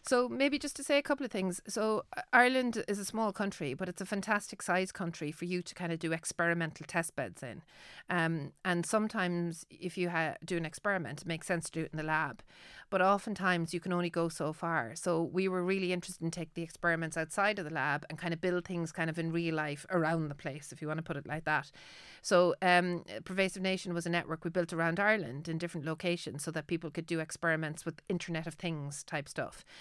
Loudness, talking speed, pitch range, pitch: -34 LUFS, 235 wpm, 160-190 Hz, 170 Hz